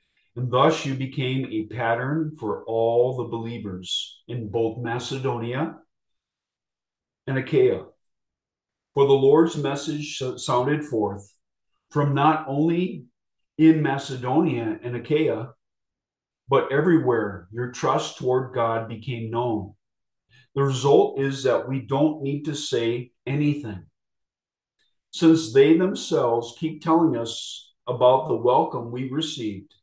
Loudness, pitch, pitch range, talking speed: -23 LUFS, 130 Hz, 115-145 Hz, 115 wpm